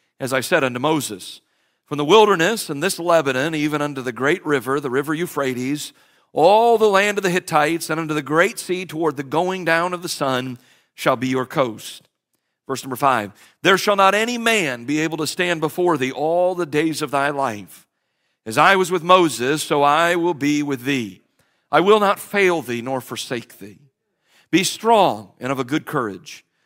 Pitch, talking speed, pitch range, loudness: 155 Hz, 195 wpm, 135-180 Hz, -19 LUFS